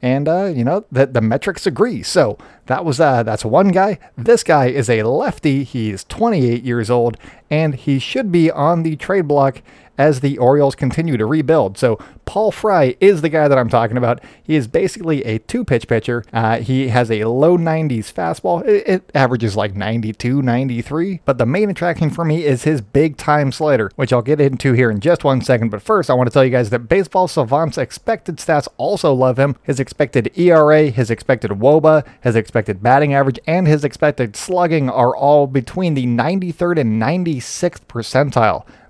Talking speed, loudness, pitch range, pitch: 195 wpm, -16 LUFS, 120-160 Hz, 140 Hz